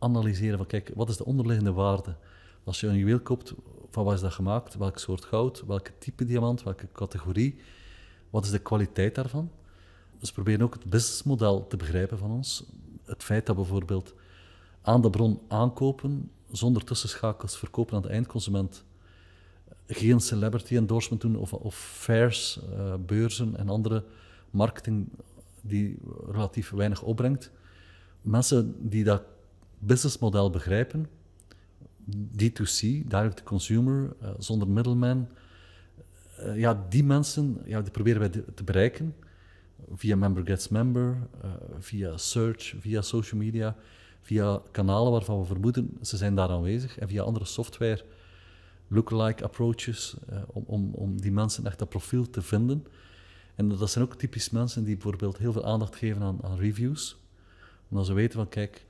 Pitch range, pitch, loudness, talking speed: 95-115 Hz, 105 Hz, -28 LUFS, 150 wpm